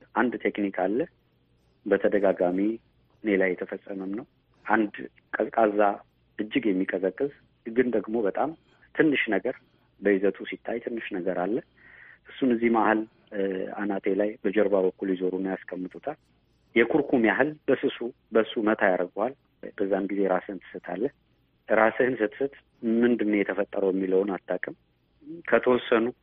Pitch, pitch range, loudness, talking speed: 105 Hz, 95-115 Hz, -27 LUFS, 110 wpm